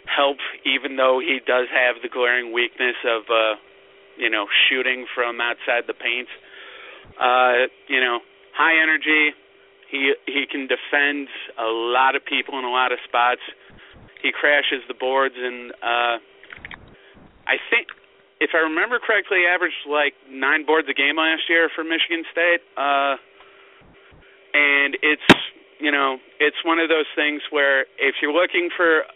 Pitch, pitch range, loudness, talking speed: 140 Hz, 125-155 Hz, -20 LUFS, 150 wpm